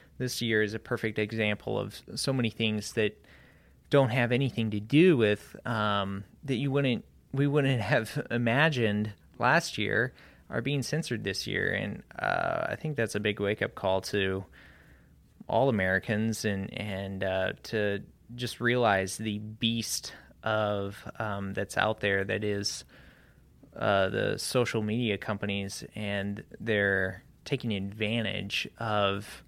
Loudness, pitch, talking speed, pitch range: -29 LUFS, 110 Hz, 140 wpm, 100-120 Hz